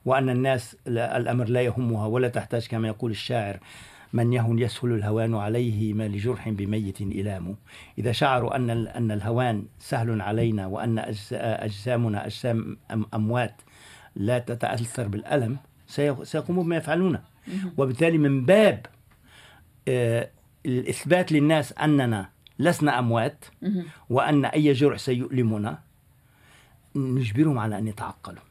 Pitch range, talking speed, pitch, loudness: 110-135 Hz, 110 wpm, 120 Hz, -25 LUFS